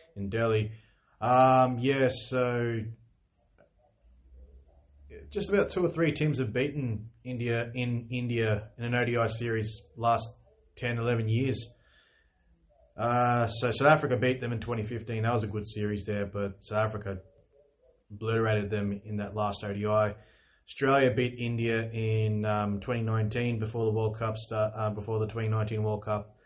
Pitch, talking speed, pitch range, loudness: 115 Hz, 150 wpm, 105-120 Hz, -29 LUFS